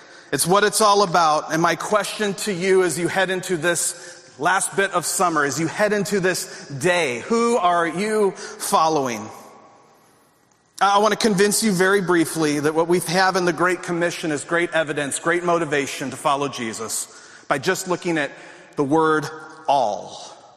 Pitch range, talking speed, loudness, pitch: 155-190 Hz, 170 wpm, -20 LUFS, 175 Hz